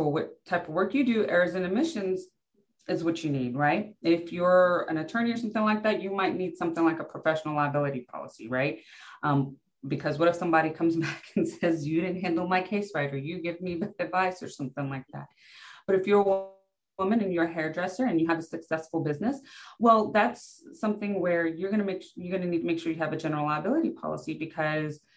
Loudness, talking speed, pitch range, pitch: -28 LUFS, 215 wpm, 160-195 Hz, 175 Hz